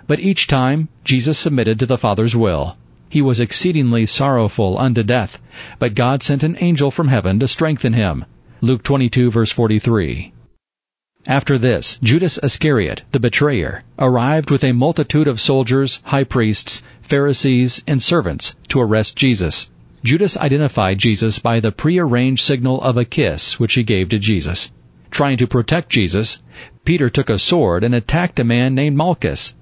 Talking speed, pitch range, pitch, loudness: 160 wpm, 110-140 Hz, 125 Hz, -16 LUFS